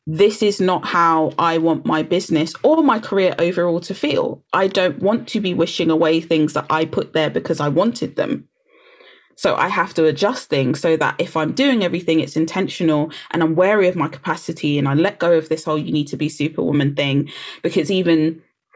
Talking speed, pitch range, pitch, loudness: 210 wpm, 155-190 Hz, 165 Hz, -18 LUFS